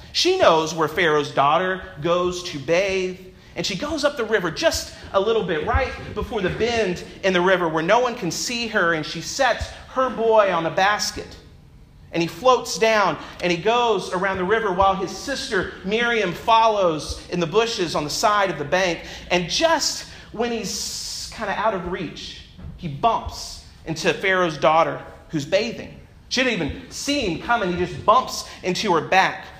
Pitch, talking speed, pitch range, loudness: 190 Hz, 185 wpm, 170-225 Hz, -21 LUFS